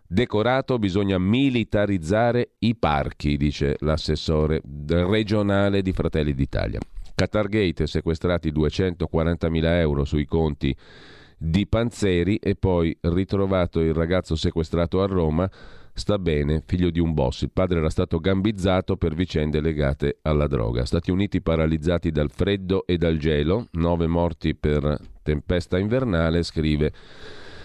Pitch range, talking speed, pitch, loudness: 80-95 Hz, 125 wpm, 85 Hz, -23 LUFS